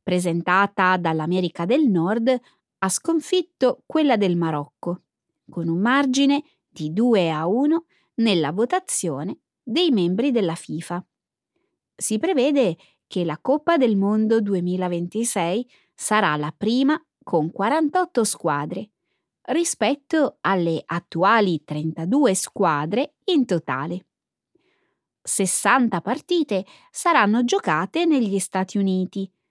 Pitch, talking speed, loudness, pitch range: 205 Hz, 100 wpm, -22 LUFS, 175-270 Hz